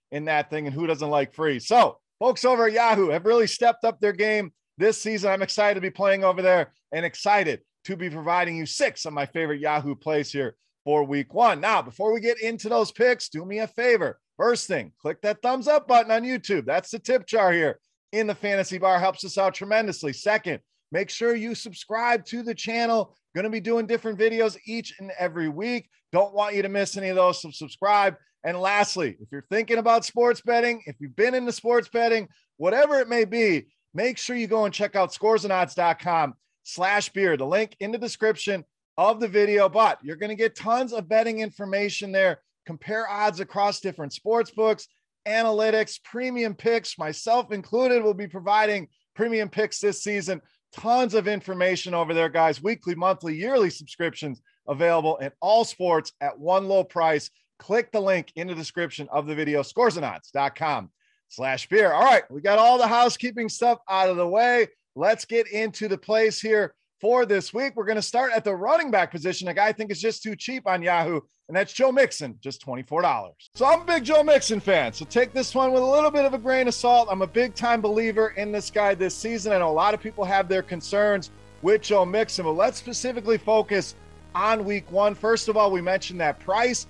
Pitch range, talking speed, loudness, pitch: 175-230 Hz, 205 wpm, -23 LUFS, 205 Hz